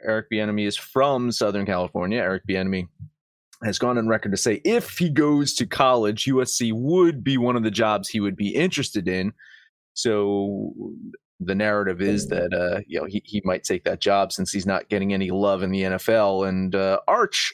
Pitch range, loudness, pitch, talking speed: 95-125 Hz, -23 LUFS, 105 Hz, 195 wpm